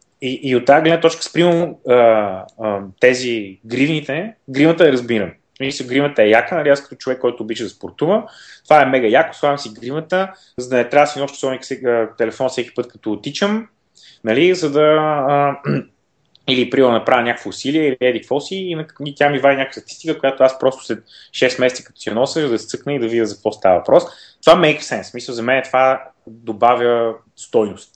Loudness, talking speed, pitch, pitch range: -16 LUFS, 205 wpm, 130 Hz, 120-145 Hz